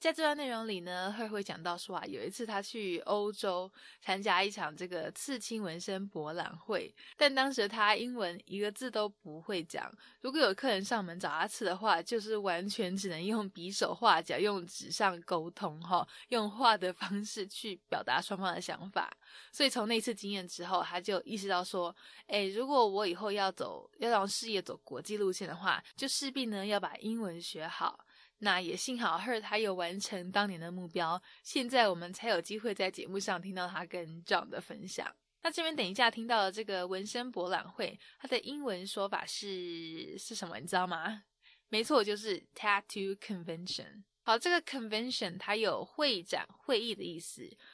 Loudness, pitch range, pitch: -35 LUFS, 180-225 Hz, 200 Hz